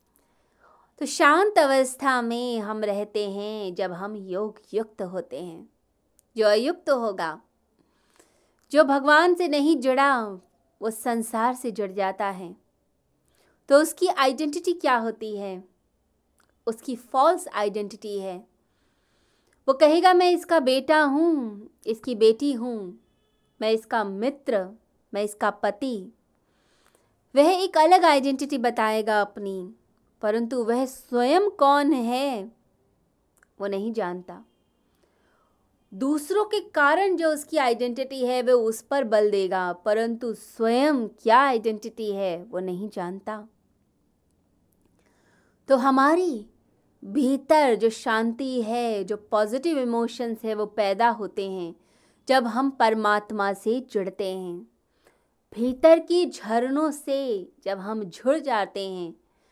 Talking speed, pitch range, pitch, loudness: 115 wpm, 210-275 Hz, 230 Hz, -24 LUFS